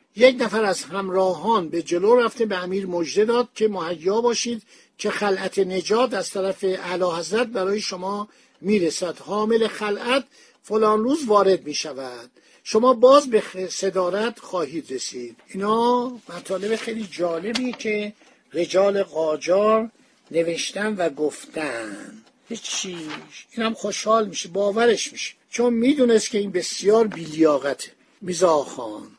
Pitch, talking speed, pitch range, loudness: 210 Hz, 130 wpm, 185-230 Hz, -22 LUFS